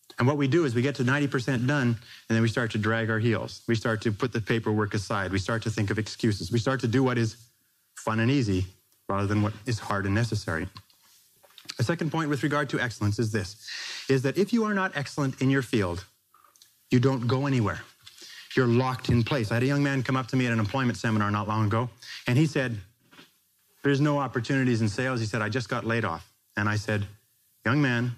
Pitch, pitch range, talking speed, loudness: 120 Hz, 110-135 Hz, 235 wpm, -27 LUFS